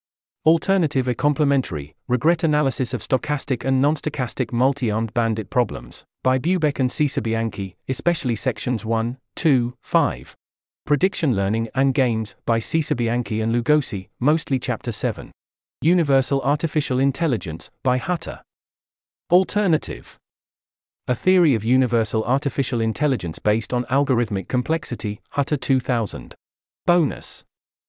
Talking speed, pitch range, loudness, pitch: 115 wpm, 110-145 Hz, -22 LUFS, 125 Hz